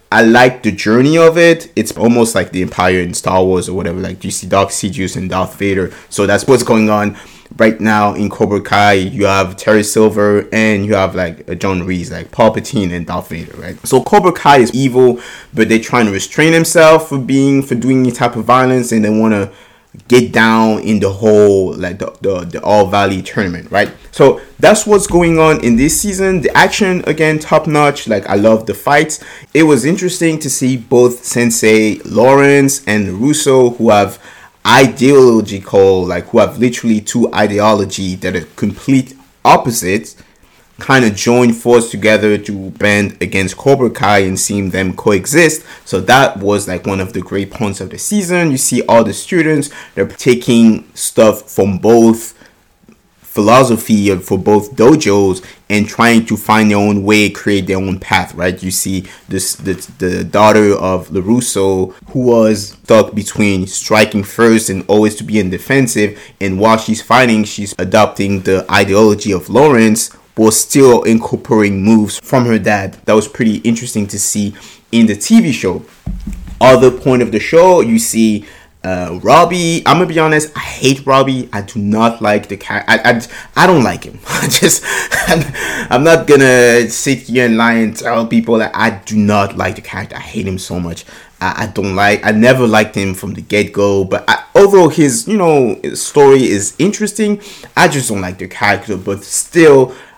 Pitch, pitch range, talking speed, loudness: 110 Hz, 100-130 Hz, 185 wpm, -11 LUFS